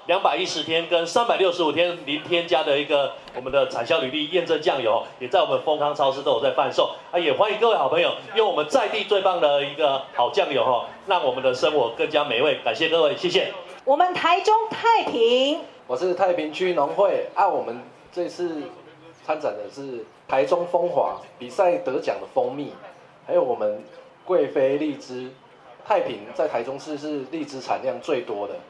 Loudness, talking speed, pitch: -22 LUFS, 285 characters per minute, 175 Hz